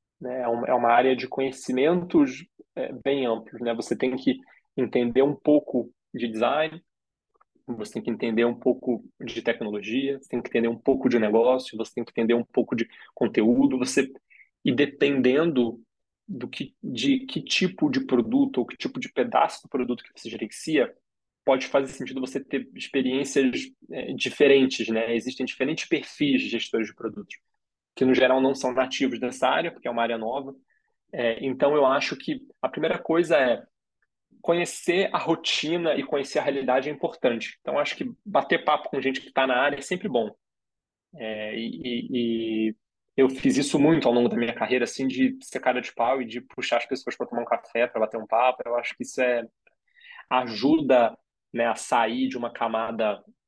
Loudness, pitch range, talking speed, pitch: -25 LUFS, 120-140 Hz, 185 wpm, 130 Hz